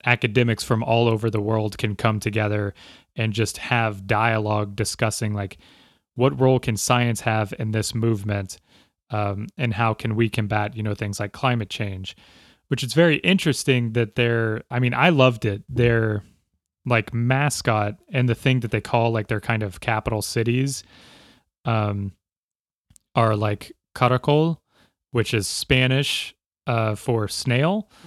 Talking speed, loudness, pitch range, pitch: 150 wpm, -22 LUFS, 105-125 Hz, 115 Hz